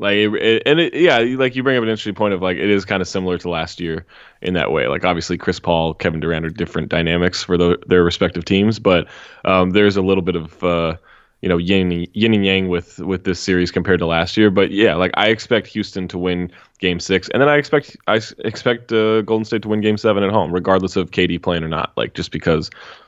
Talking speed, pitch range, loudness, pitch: 250 wpm, 85-105 Hz, -17 LUFS, 95 Hz